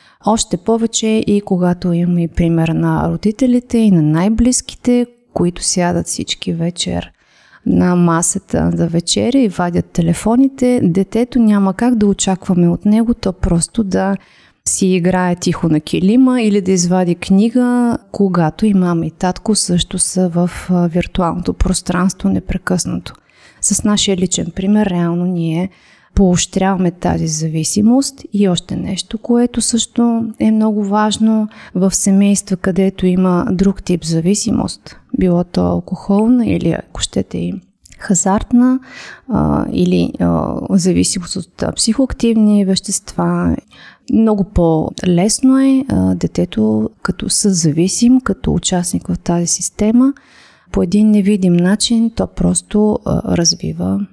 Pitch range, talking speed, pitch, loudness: 175-220 Hz, 120 wpm, 190 Hz, -14 LUFS